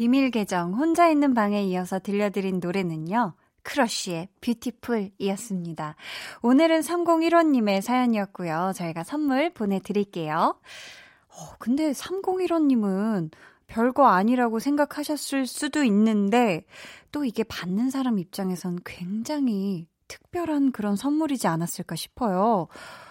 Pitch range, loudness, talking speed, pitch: 190-280 Hz, -25 LUFS, 280 characters per minute, 225 Hz